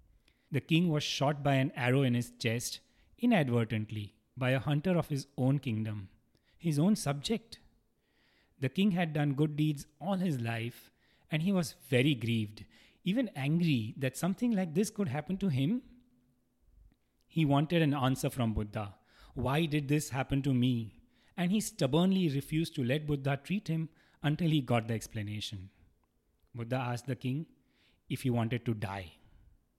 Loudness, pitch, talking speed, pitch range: -32 LUFS, 140 Hz, 160 wpm, 115-160 Hz